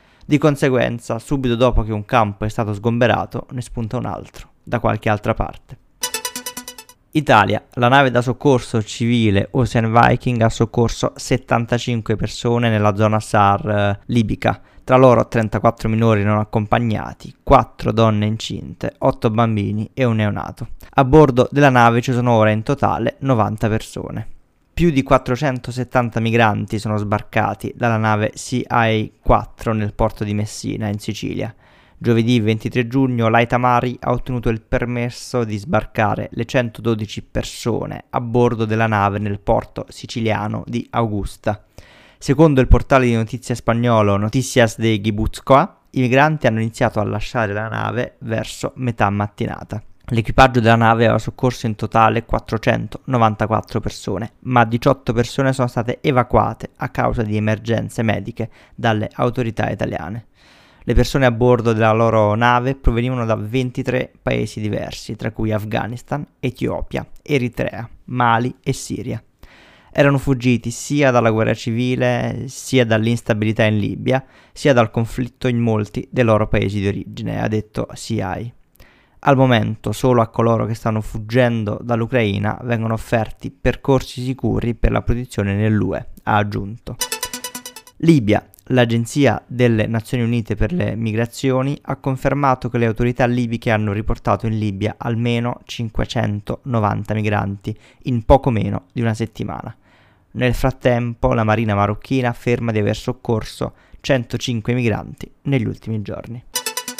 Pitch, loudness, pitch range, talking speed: 115 Hz, -18 LUFS, 110-125 Hz, 135 wpm